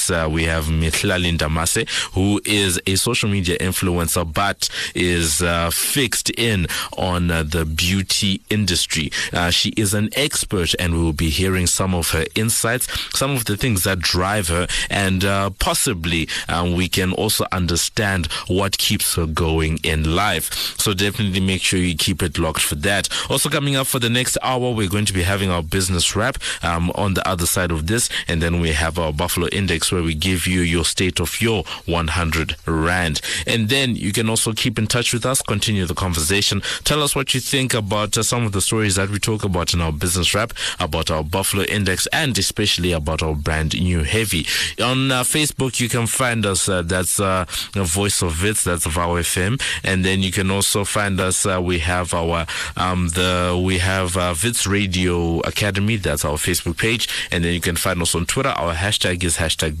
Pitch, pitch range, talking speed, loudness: 95 Hz, 85-105 Hz, 200 wpm, -19 LUFS